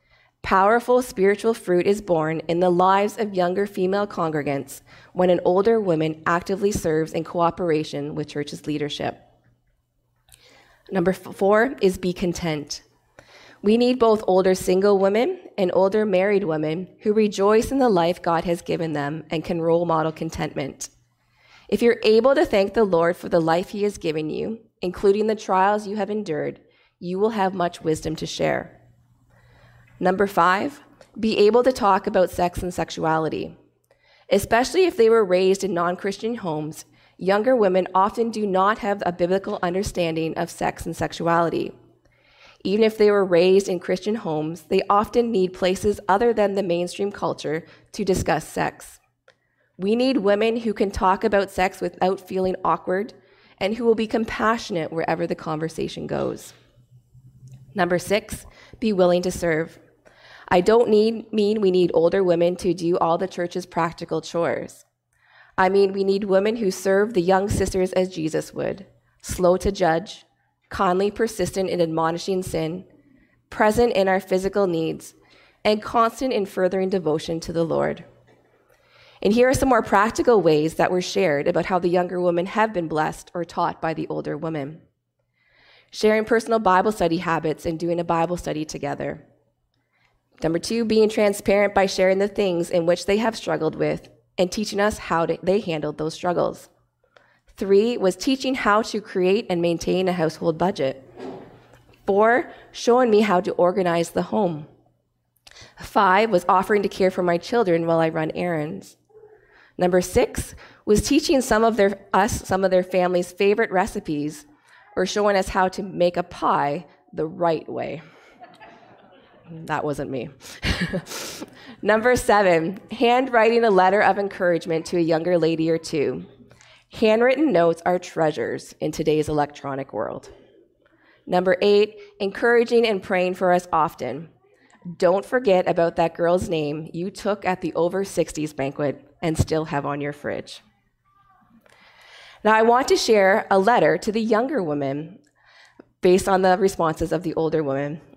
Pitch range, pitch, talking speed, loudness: 165-210 Hz, 185 Hz, 160 wpm, -21 LUFS